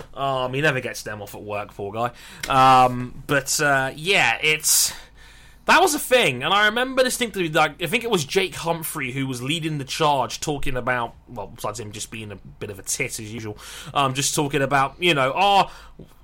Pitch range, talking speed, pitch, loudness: 125-165 Hz, 210 wpm, 140 Hz, -21 LUFS